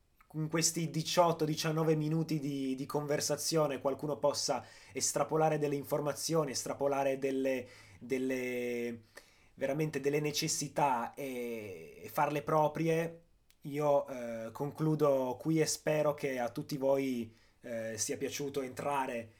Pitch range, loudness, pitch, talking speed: 130-155 Hz, -34 LUFS, 145 Hz, 110 wpm